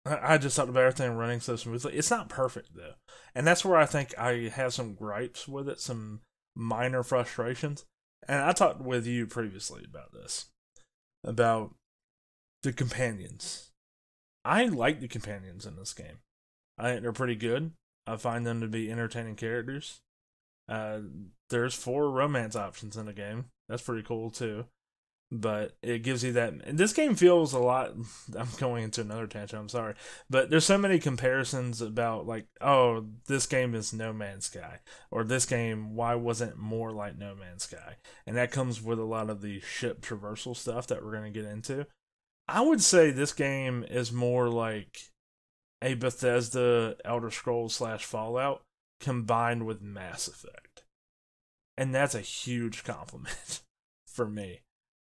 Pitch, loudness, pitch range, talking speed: 120 Hz, -30 LUFS, 110-130 Hz, 165 wpm